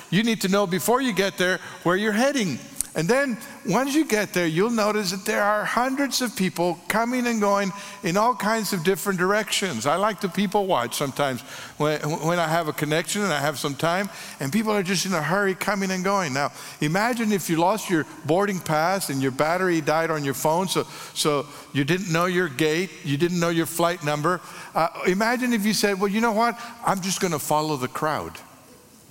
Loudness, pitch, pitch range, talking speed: -23 LUFS, 190 Hz, 160-210 Hz, 215 wpm